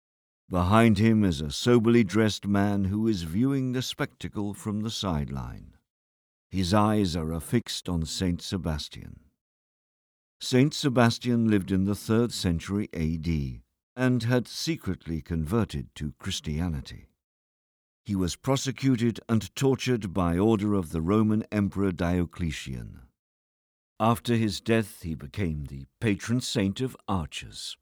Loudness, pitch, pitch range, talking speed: -27 LUFS, 100 Hz, 80-115 Hz, 125 wpm